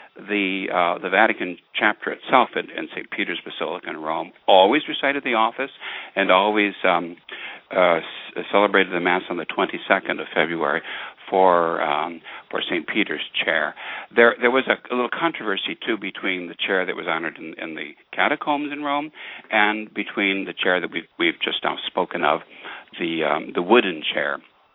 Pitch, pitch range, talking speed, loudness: 105 Hz, 95-130 Hz, 175 wpm, -21 LUFS